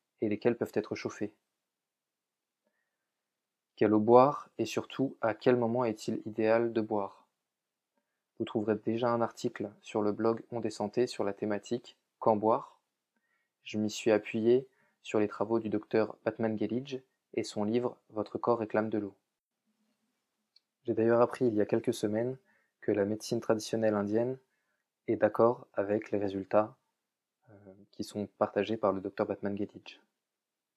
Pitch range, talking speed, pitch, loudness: 105-120 Hz, 150 wpm, 110 Hz, -32 LUFS